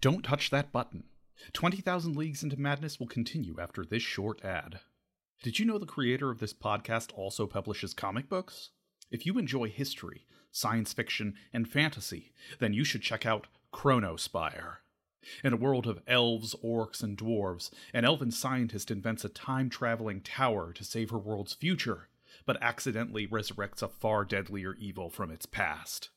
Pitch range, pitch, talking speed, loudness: 105-135 Hz, 115 Hz, 165 wpm, -33 LUFS